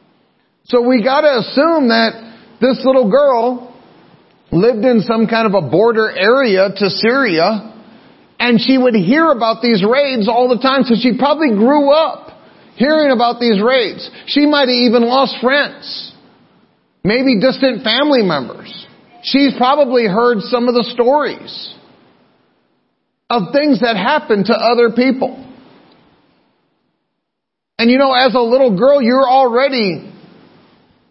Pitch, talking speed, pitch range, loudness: 245 Hz, 135 wpm, 230-265 Hz, -13 LUFS